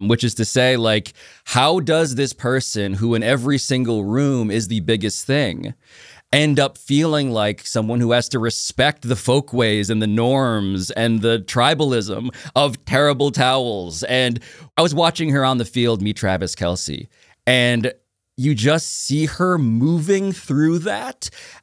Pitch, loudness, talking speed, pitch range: 125 Hz, -19 LUFS, 160 wpm, 110-140 Hz